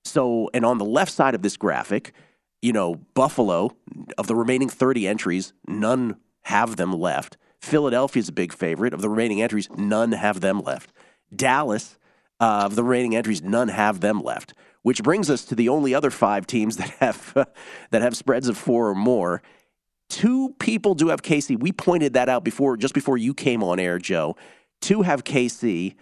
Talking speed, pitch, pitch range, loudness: 185 wpm, 120 Hz, 105-135 Hz, -22 LUFS